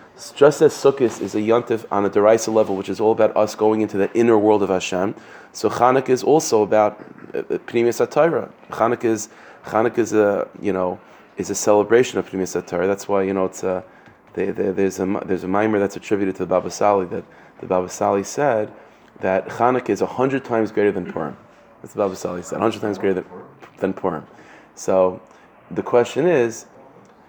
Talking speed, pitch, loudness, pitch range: 195 wpm, 105 Hz, -20 LUFS, 95-110 Hz